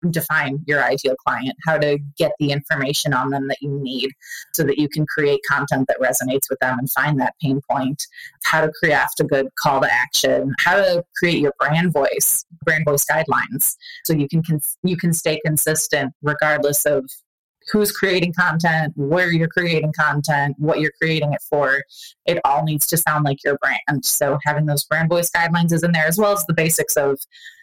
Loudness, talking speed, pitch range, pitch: -19 LUFS, 200 wpm, 145-170 Hz, 150 Hz